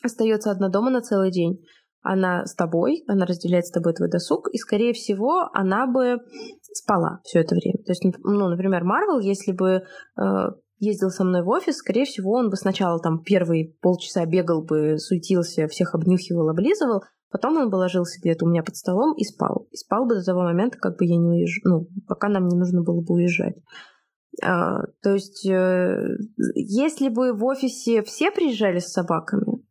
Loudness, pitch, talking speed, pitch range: -22 LUFS, 190 Hz, 190 wpm, 175-230 Hz